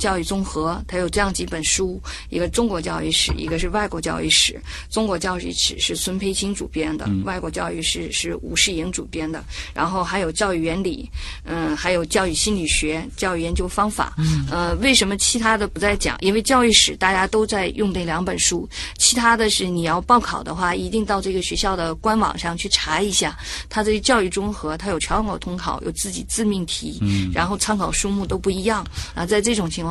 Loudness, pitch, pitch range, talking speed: -20 LUFS, 185 Hz, 160-205 Hz, 315 characters per minute